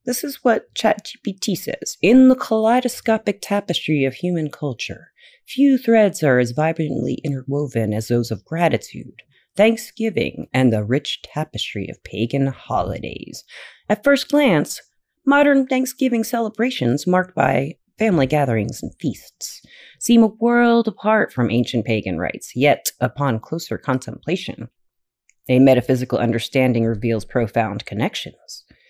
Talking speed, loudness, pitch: 125 wpm, -19 LUFS, 160 Hz